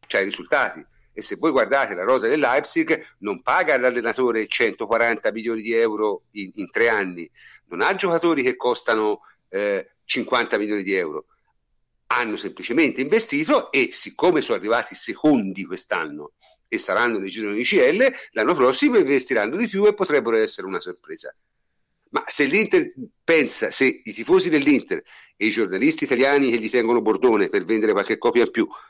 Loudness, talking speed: -21 LUFS, 165 wpm